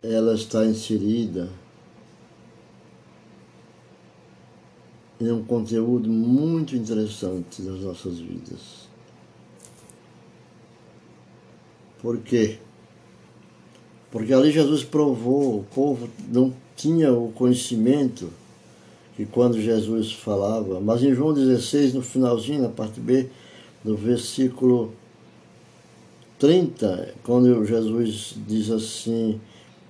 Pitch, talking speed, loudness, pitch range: 115 Hz, 85 wpm, -22 LUFS, 110-125 Hz